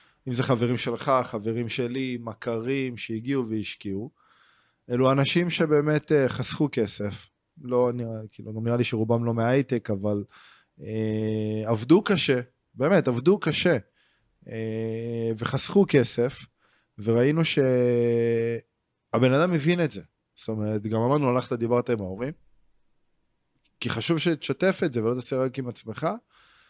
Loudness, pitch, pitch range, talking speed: -25 LUFS, 120 Hz, 115-140 Hz, 130 wpm